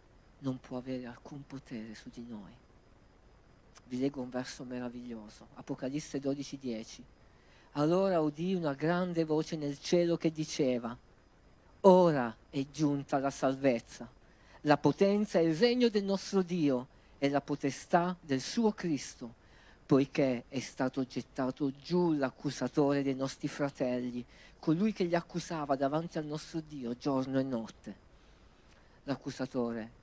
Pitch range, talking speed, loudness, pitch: 125-155 Hz, 130 wpm, -33 LUFS, 140 Hz